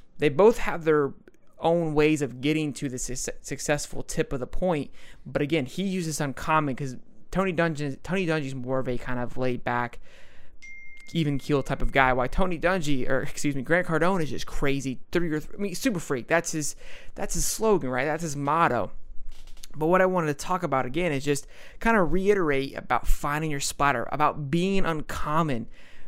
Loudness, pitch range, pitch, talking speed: -26 LUFS, 135-170 Hz, 150 Hz, 195 wpm